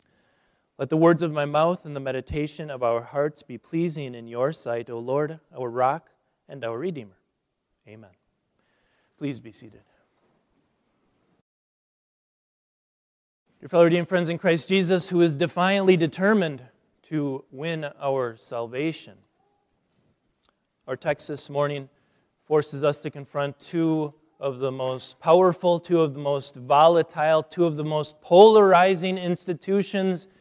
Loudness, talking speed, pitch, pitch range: -23 LUFS, 130 wpm, 150 Hz, 135-170 Hz